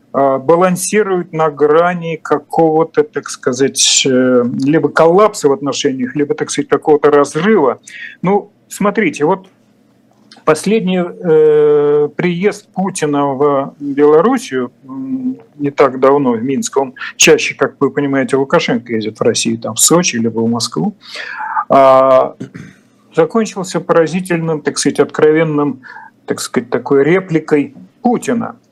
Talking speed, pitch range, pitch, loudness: 115 wpm, 140-185 Hz, 155 Hz, -13 LUFS